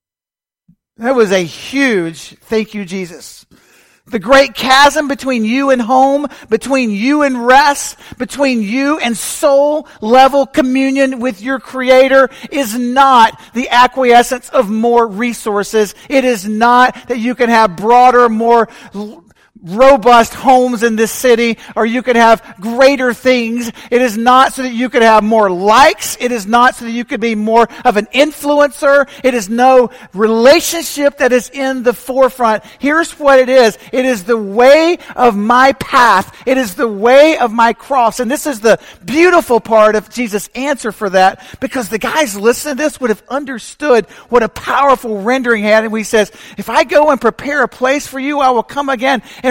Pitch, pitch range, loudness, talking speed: 245 Hz, 225-270 Hz, -11 LUFS, 175 wpm